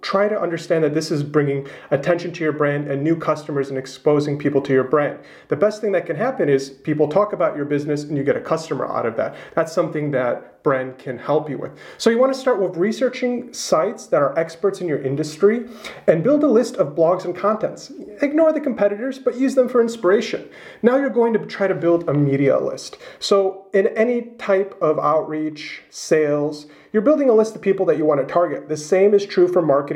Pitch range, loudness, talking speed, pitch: 150-220 Hz, -20 LUFS, 225 wpm, 175 Hz